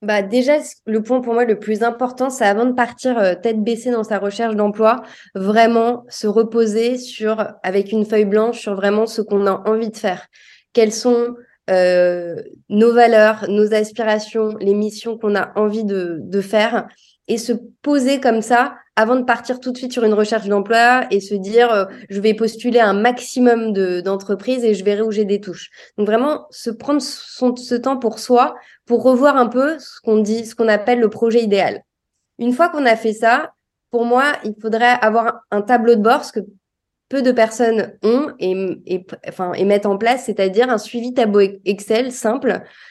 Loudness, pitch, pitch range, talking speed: -17 LUFS, 225 Hz, 210-240 Hz, 195 wpm